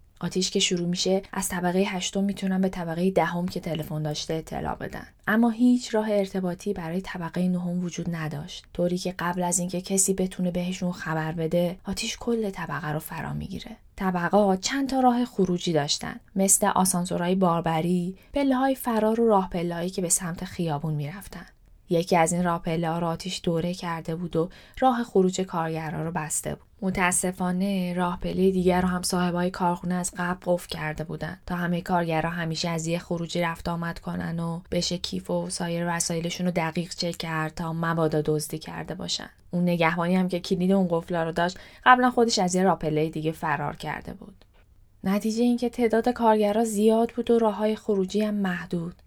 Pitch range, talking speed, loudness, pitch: 170-195 Hz, 180 wpm, -26 LUFS, 180 Hz